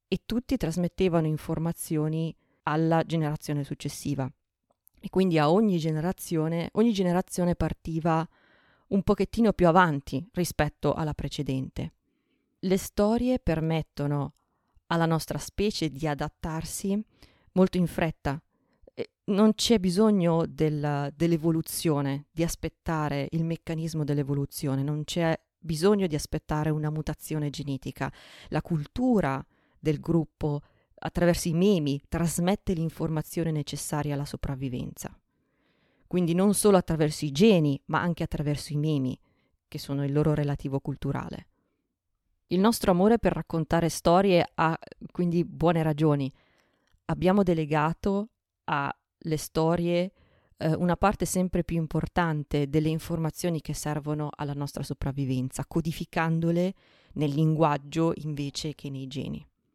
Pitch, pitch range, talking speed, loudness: 160 Hz, 150-175 Hz, 115 wpm, -27 LUFS